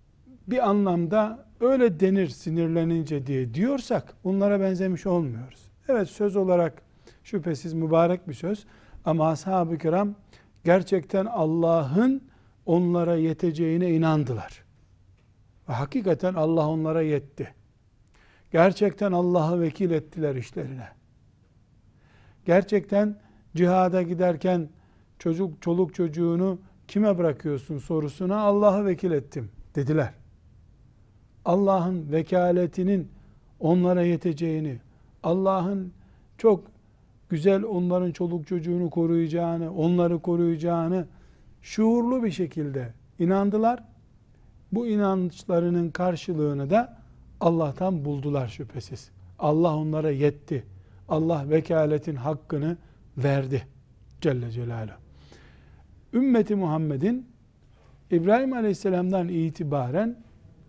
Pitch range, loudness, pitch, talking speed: 140-185 Hz, -25 LUFS, 165 Hz, 85 wpm